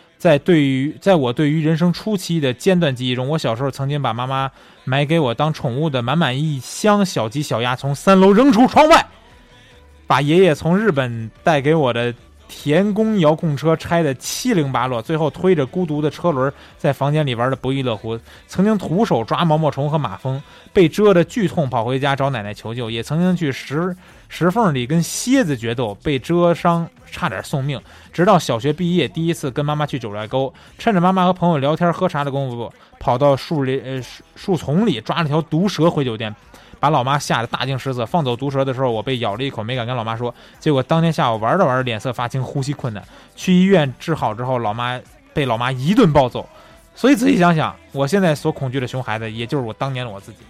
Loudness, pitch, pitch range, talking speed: -18 LUFS, 145 Hz, 125-170 Hz, 320 characters per minute